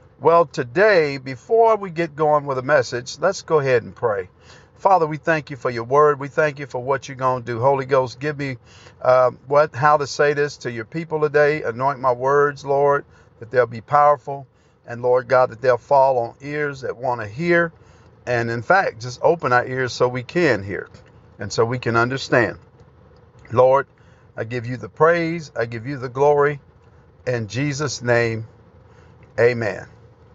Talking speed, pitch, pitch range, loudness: 190 wpm, 130 Hz, 120-145 Hz, -20 LUFS